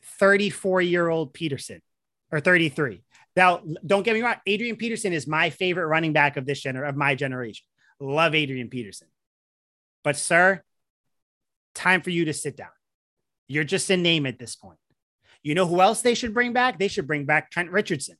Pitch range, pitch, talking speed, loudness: 145-190 Hz, 165 Hz, 185 wpm, -23 LUFS